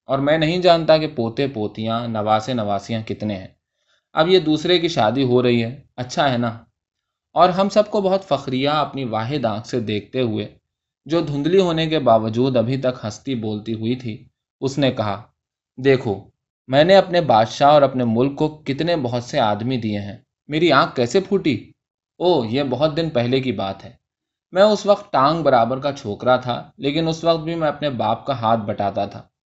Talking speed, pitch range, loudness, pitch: 190 wpm, 115-155 Hz, -19 LUFS, 130 Hz